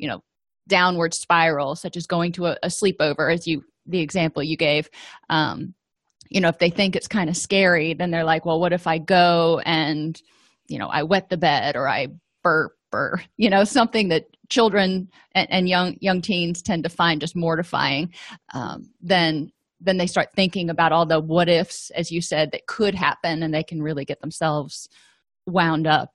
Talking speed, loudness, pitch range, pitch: 195 wpm, -21 LUFS, 160-185 Hz, 170 Hz